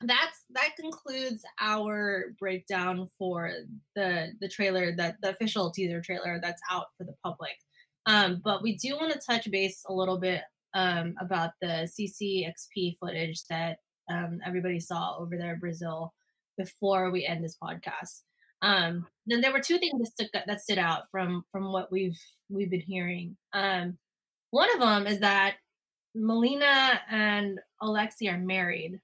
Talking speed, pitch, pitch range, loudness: 155 wpm, 190 Hz, 175-215 Hz, -29 LUFS